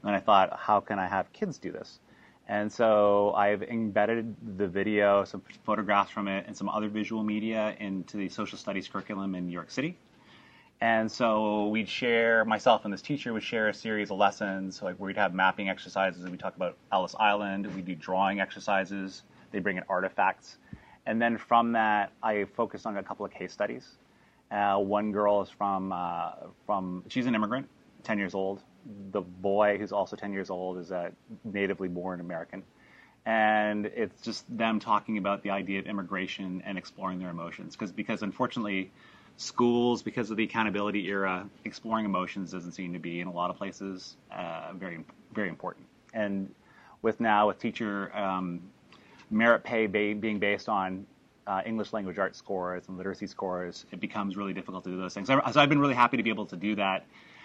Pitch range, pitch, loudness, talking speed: 95-110 Hz, 100 Hz, -30 LUFS, 185 wpm